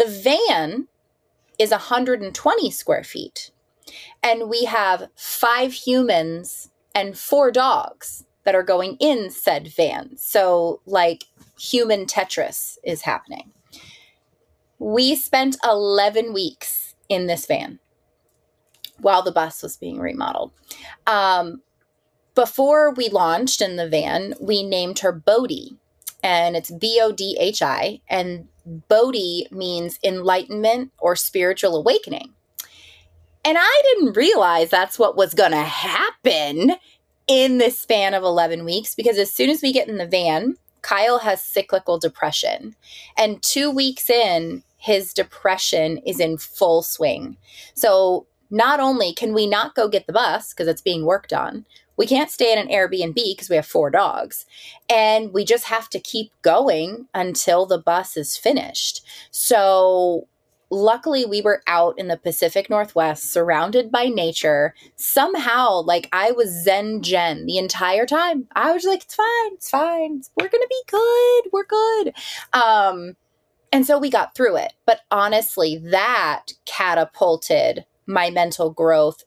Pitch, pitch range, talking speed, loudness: 205 Hz, 175-255 Hz, 140 wpm, -19 LUFS